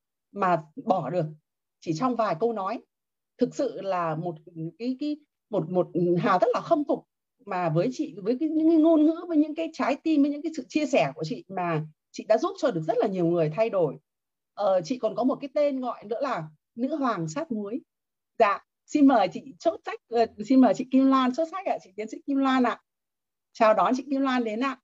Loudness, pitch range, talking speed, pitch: -26 LUFS, 185-290 Hz, 235 wpm, 245 Hz